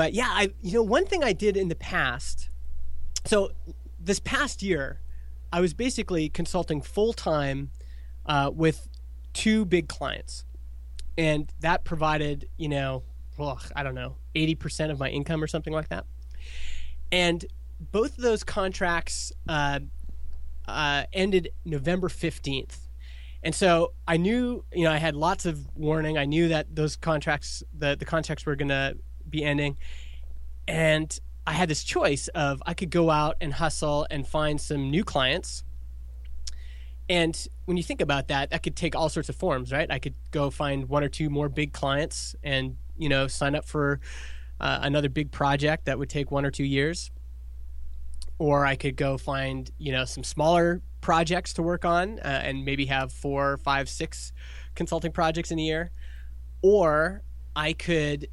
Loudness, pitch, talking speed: -27 LUFS, 145 Hz, 170 wpm